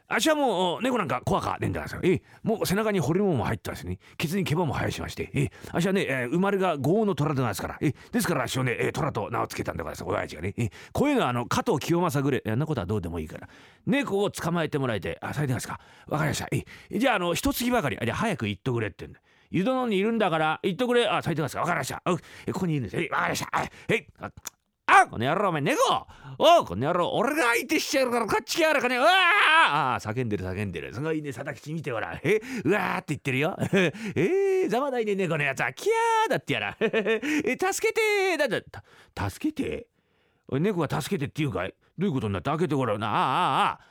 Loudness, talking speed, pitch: -26 LUFS, 495 characters per minute, 170 Hz